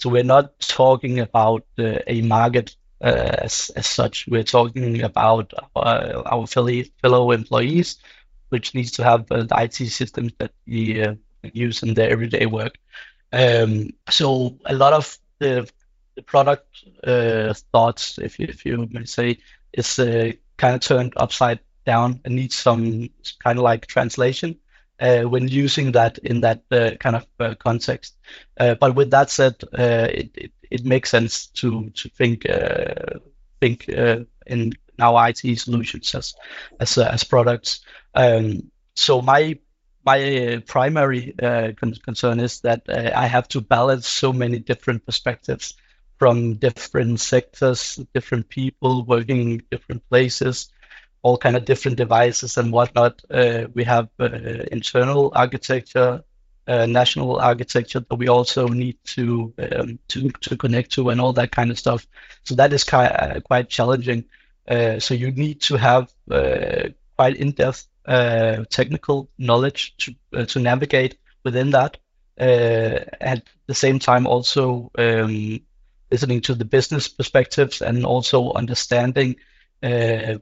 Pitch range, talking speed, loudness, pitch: 115-130 Hz, 150 wpm, -19 LUFS, 125 Hz